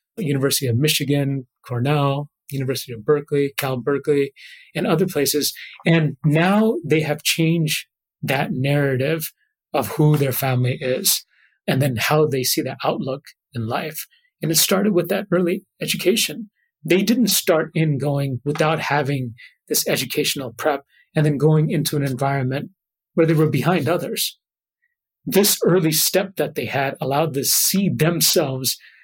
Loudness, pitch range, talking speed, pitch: -20 LUFS, 140-175 Hz, 150 wpm, 150 Hz